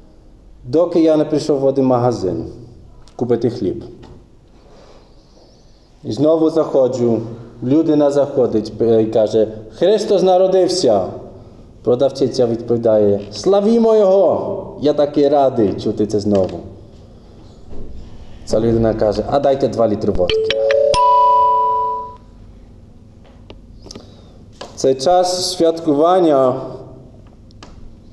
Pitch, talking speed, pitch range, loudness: 120 Hz, 85 wpm, 110-155 Hz, -15 LUFS